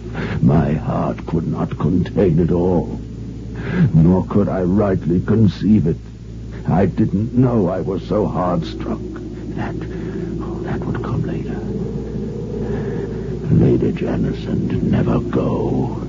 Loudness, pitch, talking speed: -19 LUFS, 90 Hz, 115 wpm